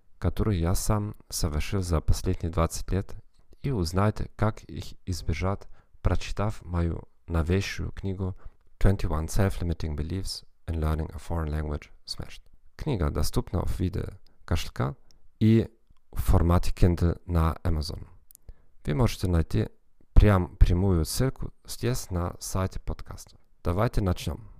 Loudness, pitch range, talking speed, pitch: -29 LUFS, 85-100 Hz, 120 wpm, 90 Hz